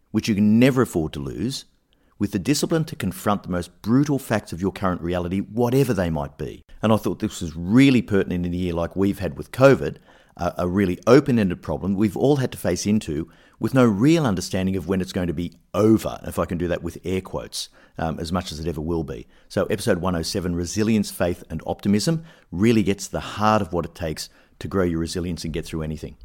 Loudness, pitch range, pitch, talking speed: -22 LUFS, 85-110 Hz, 95 Hz, 230 wpm